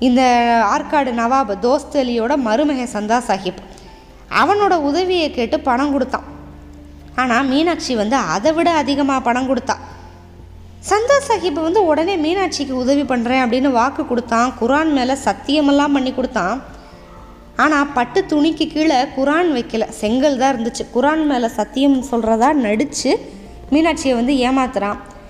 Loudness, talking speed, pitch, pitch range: -17 LUFS, 125 wpm, 260 Hz, 225-295 Hz